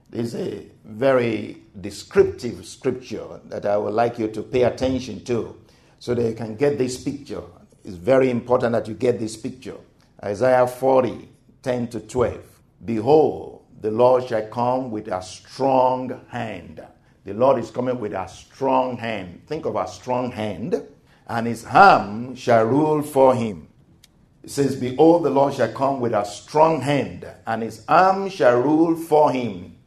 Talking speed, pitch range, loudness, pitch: 165 wpm, 110-130 Hz, -21 LUFS, 125 Hz